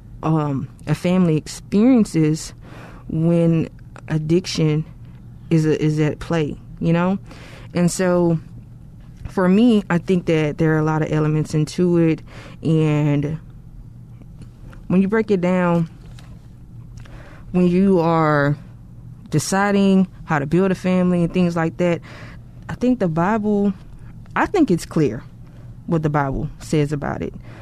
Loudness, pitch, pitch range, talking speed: -19 LUFS, 155 Hz, 140-180 Hz, 130 wpm